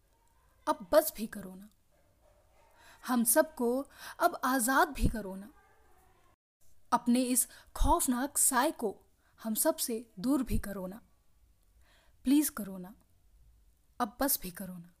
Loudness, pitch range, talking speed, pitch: -31 LUFS, 215-305 Hz, 130 wpm, 250 Hz